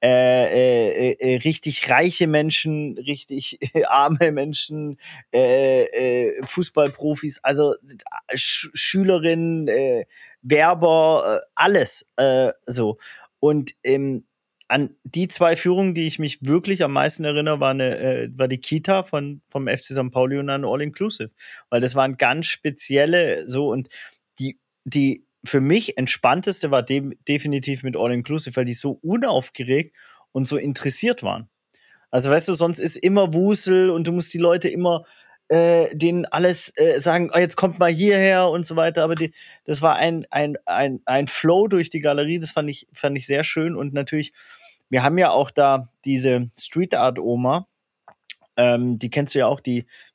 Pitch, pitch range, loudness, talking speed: 150 Hz, 135-175 Hz, -20 LUFS, 165 wpm